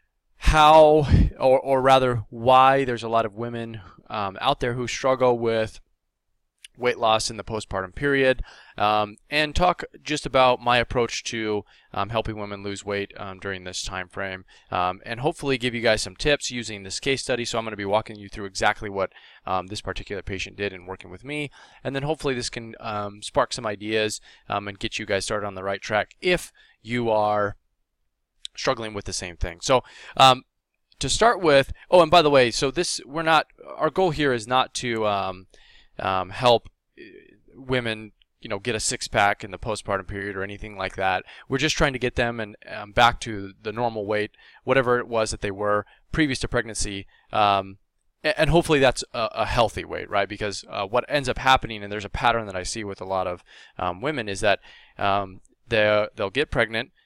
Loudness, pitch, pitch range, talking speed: -23 LUFS, 110 Hz, 100-125 Hz, 200 wpm